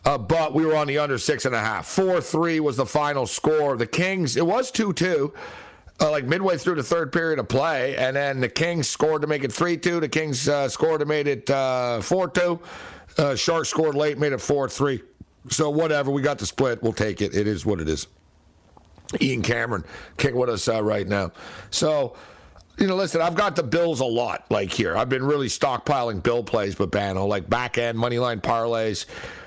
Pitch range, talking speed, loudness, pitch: 110-160 Hz, 220 wpm, -23 LUFS, 140 Hz